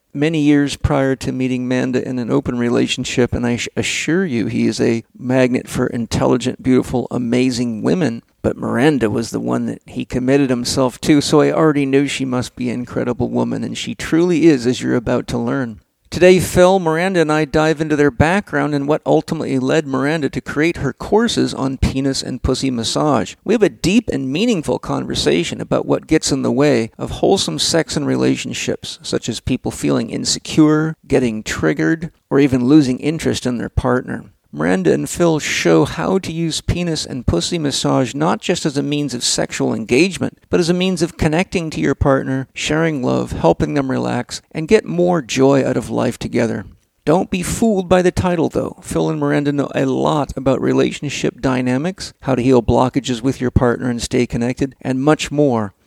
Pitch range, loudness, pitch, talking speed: 125-155 Hz, -17 LUFS, 135 Hz, 190 wpm